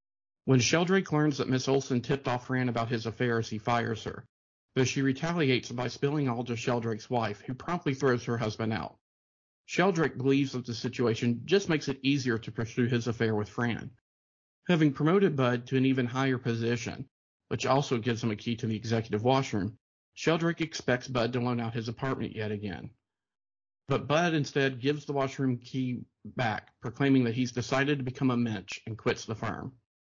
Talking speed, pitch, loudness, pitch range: 185 wpm, 125 Hz, -30 LUFS, 115-135 Hz